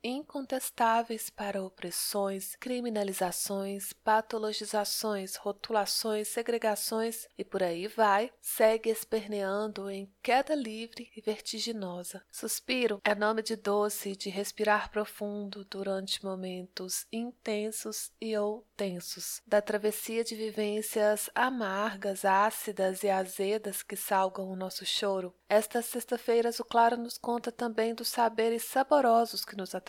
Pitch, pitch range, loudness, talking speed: 215 Hz, 195-230 Hz, -31 LUFS, 115 wpm